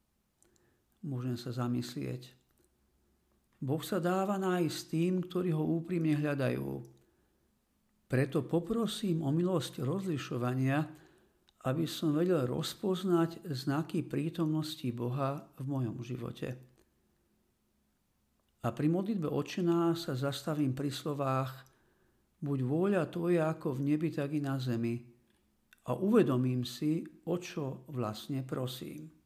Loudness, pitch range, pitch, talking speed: -34 LUFS, 125-165 Hz, 150 Hz, 105 wpm